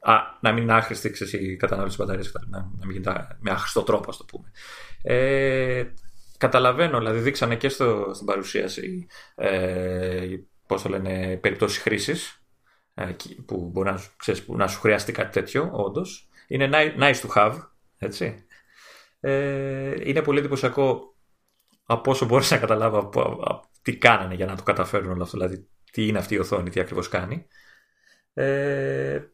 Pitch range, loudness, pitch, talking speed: 95-130 Hz, -24 LUFS, 105 Hz, 160 wpm